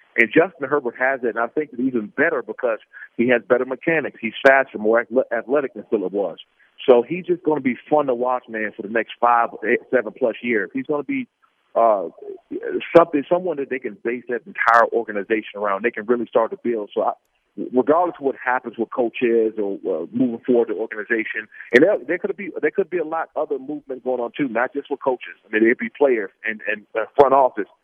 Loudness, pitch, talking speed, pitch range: -21 LUFS, 130 Hz, 230 wpm, 120-160 Hz